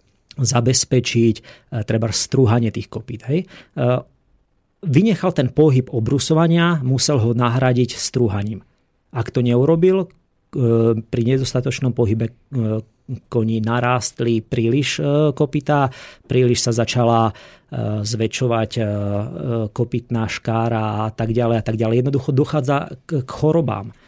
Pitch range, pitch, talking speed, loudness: 115-135 Hz, 120 Hz, 95 wpm, -19 LUFS